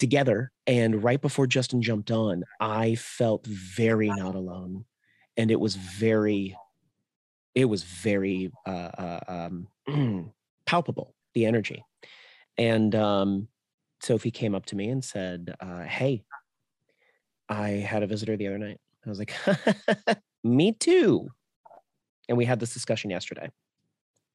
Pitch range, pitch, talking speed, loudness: 95-125 Hz, 110 Hz, 135 wpm, -27 LUFS